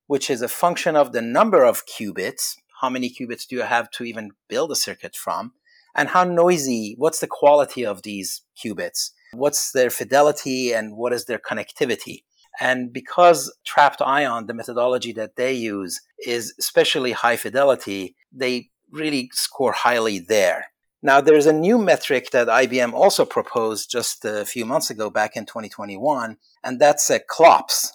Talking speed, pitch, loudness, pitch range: 165 wpm, 125 Hz, -20 LUFS, 115-155 Hz